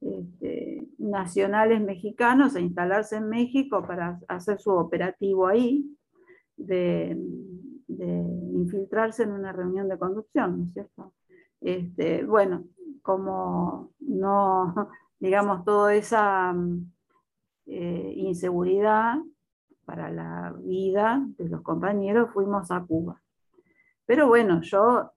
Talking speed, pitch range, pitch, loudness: 105 wpm, 180-225 Hz, 195 Hz, -26 LUFS